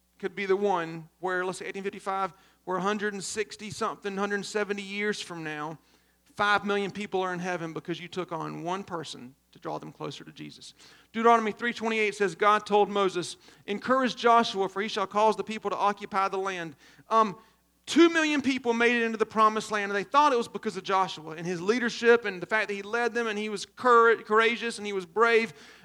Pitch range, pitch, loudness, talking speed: 185-220 Hz, 205 Hz, -27 LUFS, 200 wpm